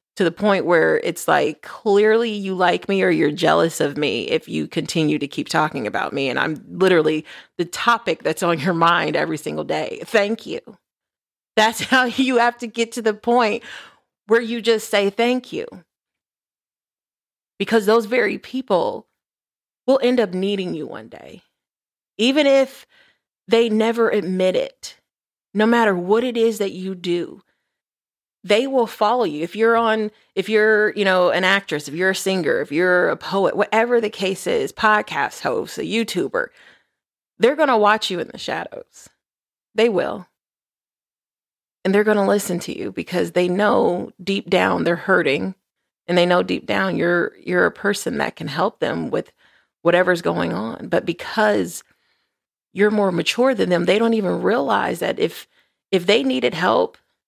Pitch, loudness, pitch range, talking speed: 210 Hz, -19 LUFS, 185-235 Hz, 170 wpm